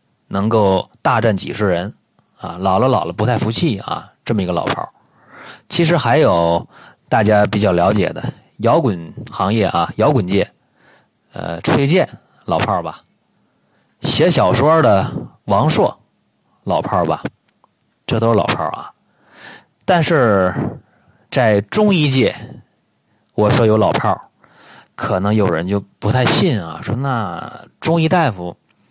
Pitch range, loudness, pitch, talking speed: 100-140 Hz, -16 LUFS, 110 Hz, 195 characters per minute